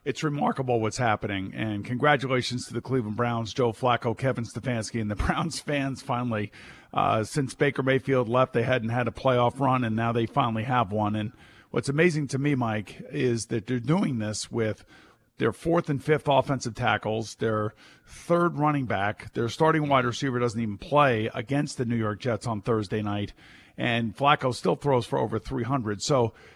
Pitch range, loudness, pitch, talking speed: 110-135 Hz, -26 LUFS, 120 Hz, 185 wpm